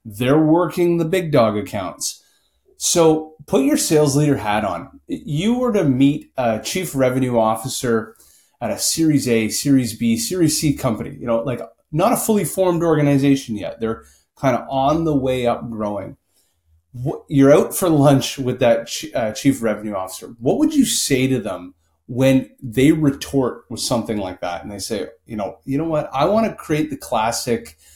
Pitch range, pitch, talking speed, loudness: 115-160 Hz, 135 Hz, 180 wpm, -19 LUFS